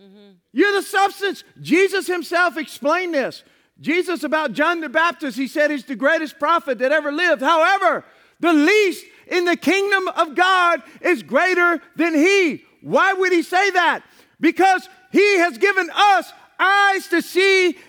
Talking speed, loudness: 155 wpm, -18 LUFS